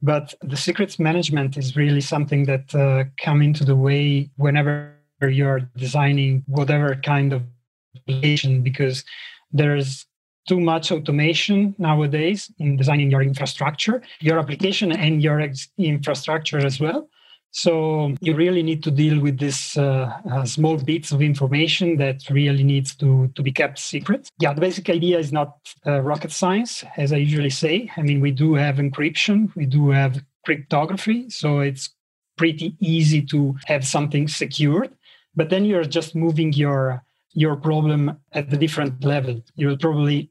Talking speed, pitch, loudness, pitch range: 160 wpm, 150 Hz, -20 LUFS, 140-160 Hz